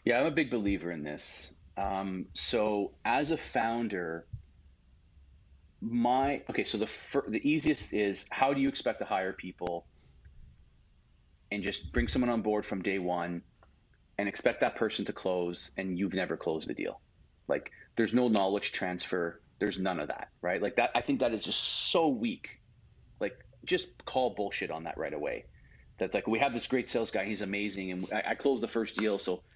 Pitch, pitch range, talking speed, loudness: 100 Hz, 85-115 Hz, 185 wpm, -32 LUFS